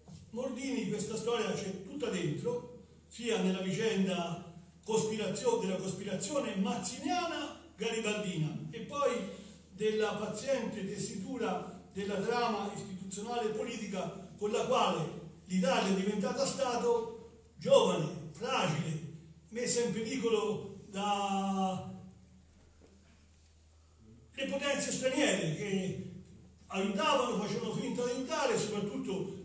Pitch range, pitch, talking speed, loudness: 185-235 Hz, 205 Hz, 95 wpm, -34 LUFS